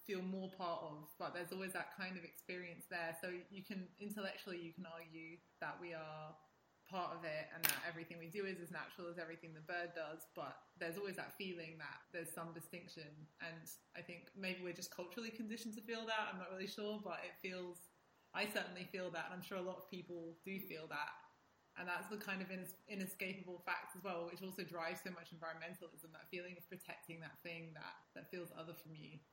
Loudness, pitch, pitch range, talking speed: -48 LUFS, 175 Hz, 165-190 Hz, 215 wpm